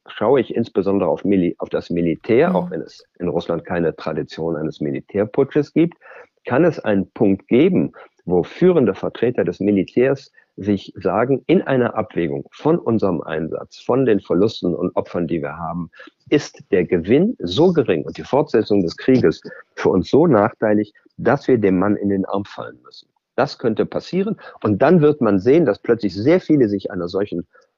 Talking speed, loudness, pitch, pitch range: 175 wpm, -19 LUFS, 100 Hz, 90-115 Hz